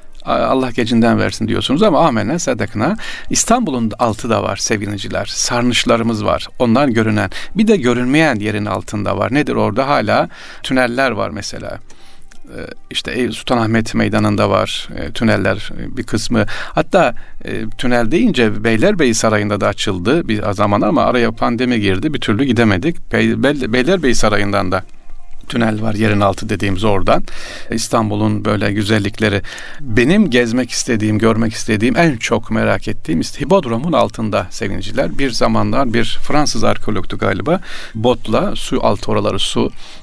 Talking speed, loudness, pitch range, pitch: 130 wpm, -16 LUFS, 105-120 Hz, 110 Hz